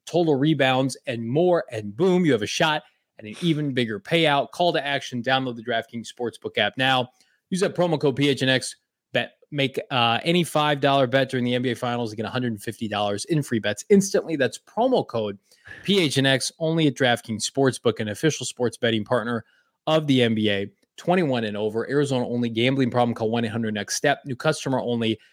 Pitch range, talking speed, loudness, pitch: 115-150 Hz, 175 wpm, -23 LUFS, 130 Hz